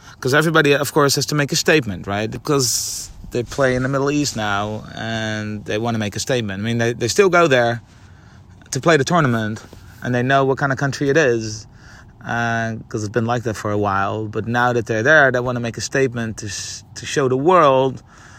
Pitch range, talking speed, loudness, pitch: 110-135 Hz, 230 wpm, -18 LUFS, 115 Hz